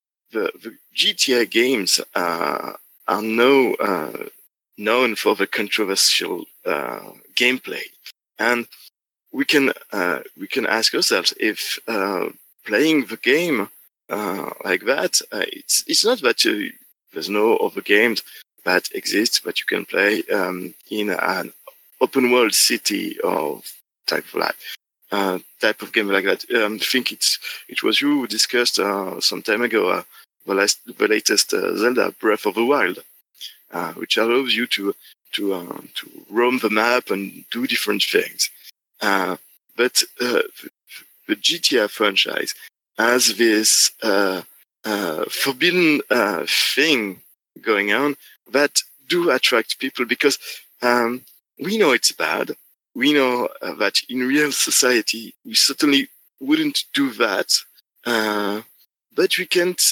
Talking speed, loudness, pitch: 145 wpm, -19 LUFS, 155 Hz